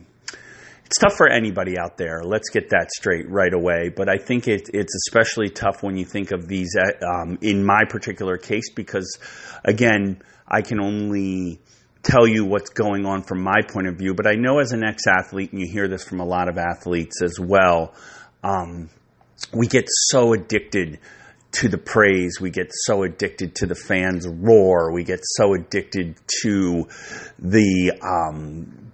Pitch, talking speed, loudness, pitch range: 95 Hz, 175 wpm, -20 LUFS, 90-105 Hz